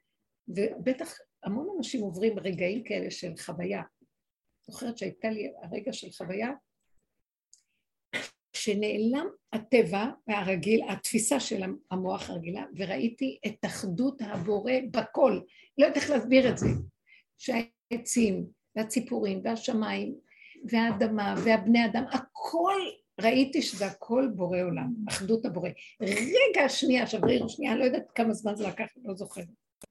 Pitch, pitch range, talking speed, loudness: 230 Hz, 205-260 Hz, 120 wpm, -29 LUFS